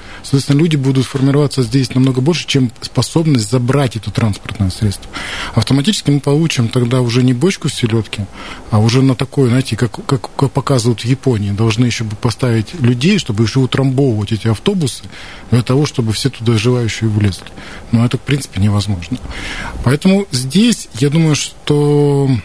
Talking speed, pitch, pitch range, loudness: 160 wpm, 130 Hz, 115-140 Hz, -14 LUFS